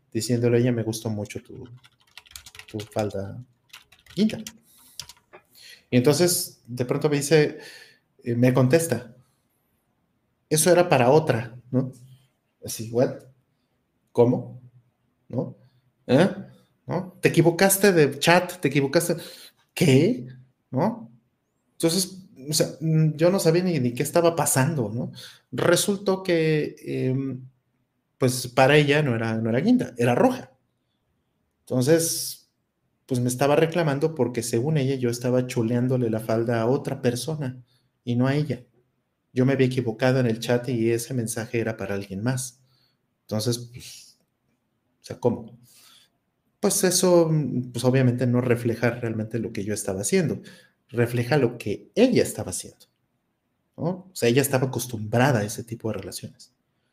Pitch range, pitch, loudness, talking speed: 120-150 Hz, 125 Hz, -23 LUFS, 135 wpm